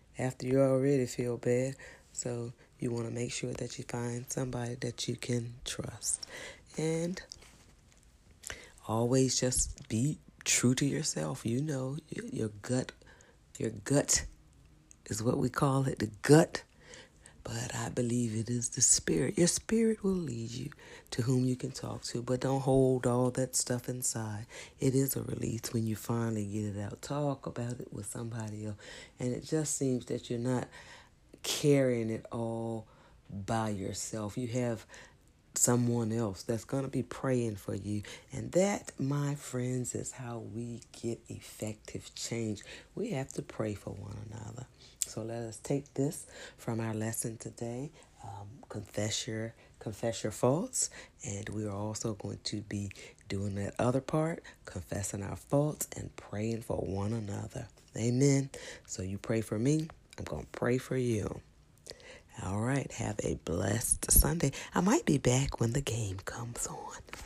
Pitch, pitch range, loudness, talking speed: 120 Hz, 110-130 Hz, -33 LUFS, 160 wpm